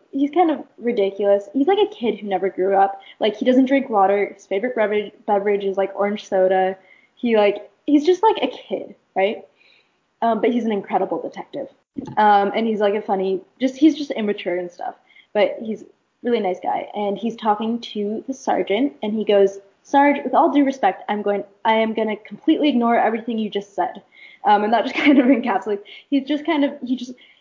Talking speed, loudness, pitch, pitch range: 210 wpm, -20 LUFS, 215 Hz, 200-270 Hz